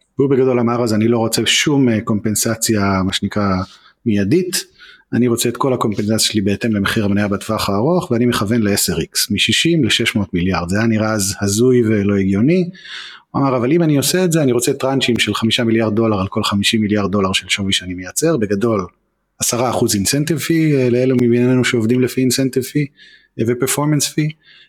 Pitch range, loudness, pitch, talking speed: 105-130 Hz, -16 LUFS, 115 Hz, 170 wpm